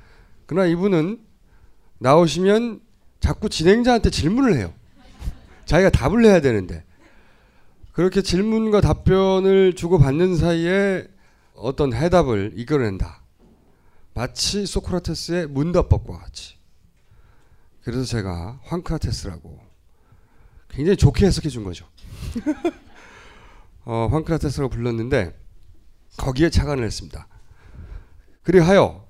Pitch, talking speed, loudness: 150 Hz, 250 characters per minute, -20 LUFS